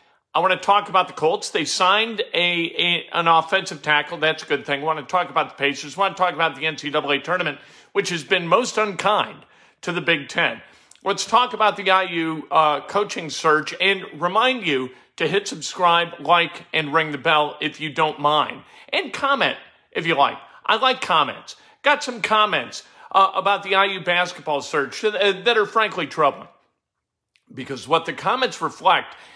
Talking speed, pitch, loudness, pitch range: 185 wpm, 175 Hz, -20 LUFS, 155-200 Hz